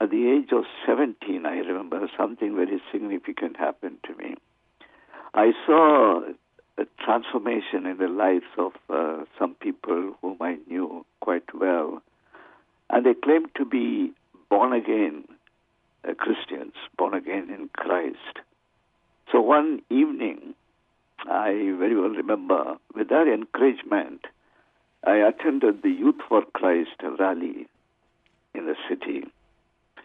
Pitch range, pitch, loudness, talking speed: 290-320 Hz, 305 Hz, -24 LUFS, 125 wpm